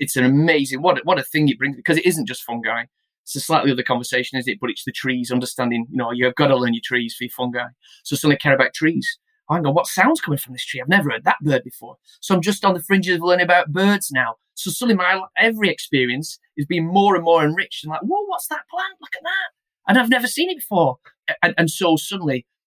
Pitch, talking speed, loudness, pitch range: 160 Hz, 265 wpm, -19 LUFS, 130-195 Hz